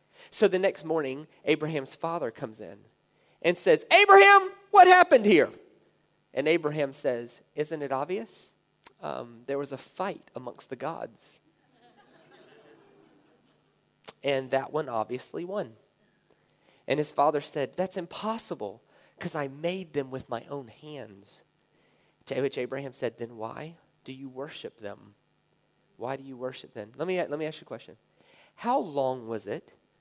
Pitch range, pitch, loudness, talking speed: 130-170 Hz, 145 Hz, -26 LUFS, 150 wpm